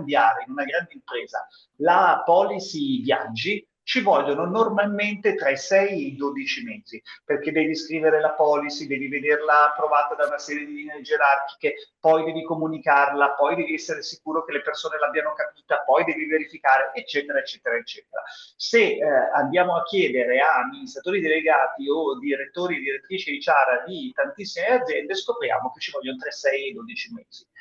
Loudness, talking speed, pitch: -23 LUFS, 165 wpm, 165 Hz